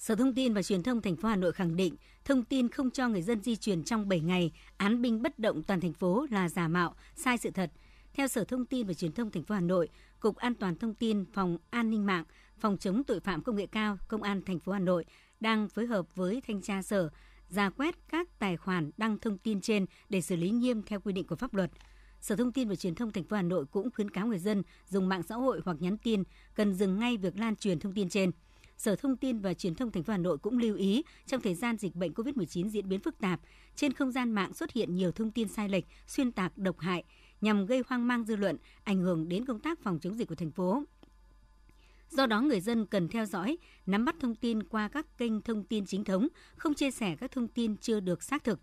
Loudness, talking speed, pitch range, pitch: -32 LUFS, 260 wpm, 185-240 Hz, 210 Hz